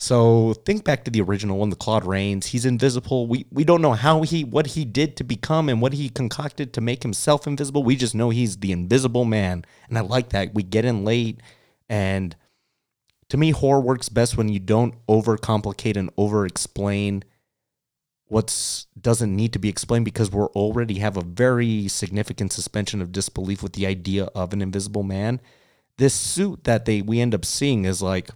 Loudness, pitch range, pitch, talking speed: -22 LUFS, 100-130 Hz, 115 Hz, 195 wpm